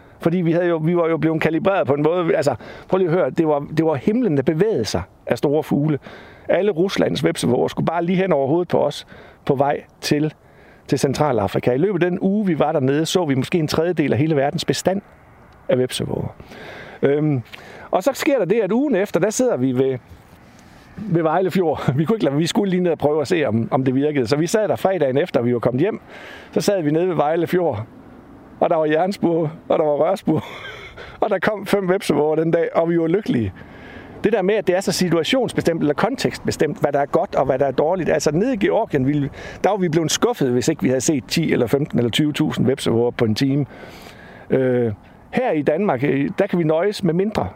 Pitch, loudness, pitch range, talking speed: 160 Hz, -19 LUFS, 140-180 Hz, 230 wpm